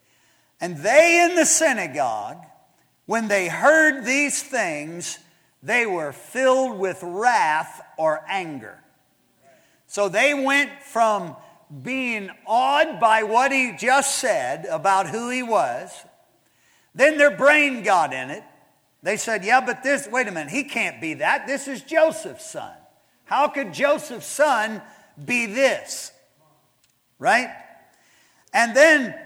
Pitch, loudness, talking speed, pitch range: 255 Hz, -20 LUFS, 130 wpm, 200-280 Hz